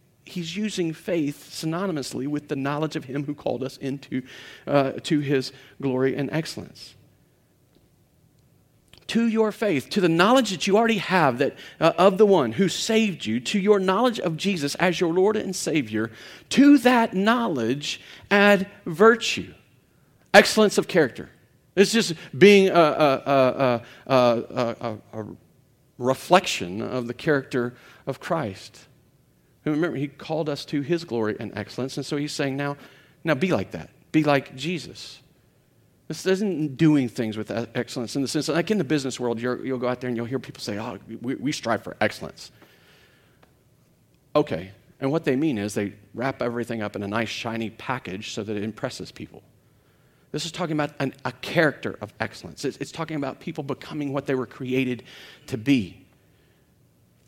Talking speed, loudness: 170 wpm, -23 LUFS